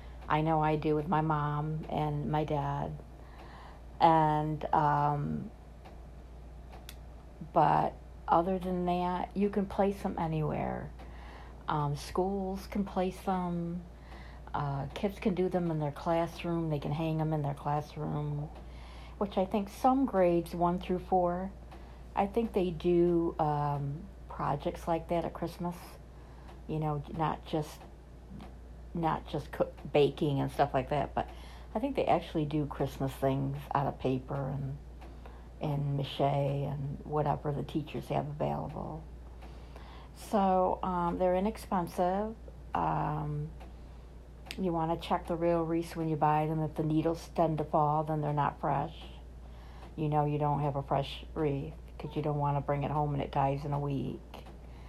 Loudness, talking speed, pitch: -32 LUFS, 150 wpm, 150 Hz